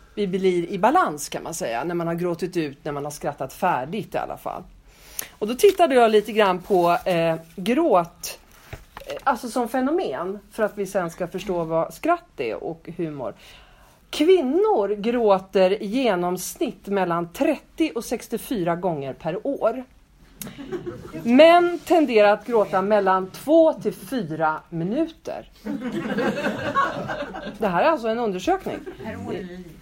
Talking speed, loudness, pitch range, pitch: 140 wpm, -22 LUFS, 175-275 Hz, 205 Hz